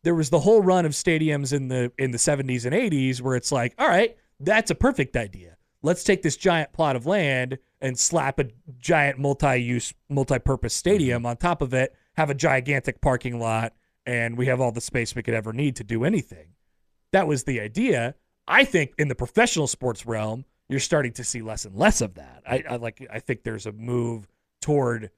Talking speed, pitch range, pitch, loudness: 210 wpm, 120-150 Hz, 130 Hz, -24 LUFS